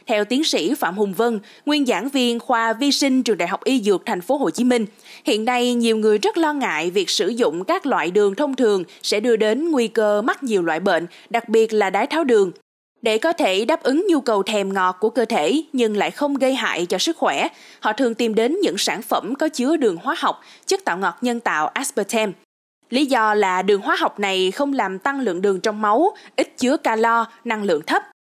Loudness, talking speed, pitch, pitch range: -20 LUFS, 235 wpm, 235 Hz, 215-290 Hz